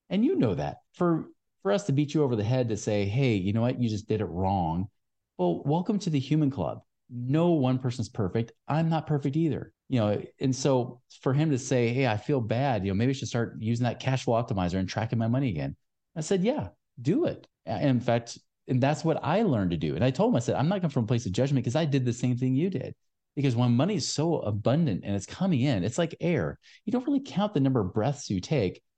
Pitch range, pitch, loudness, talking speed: 115-155 Hz, 130 Hz, -28 LUFS, 260 wpm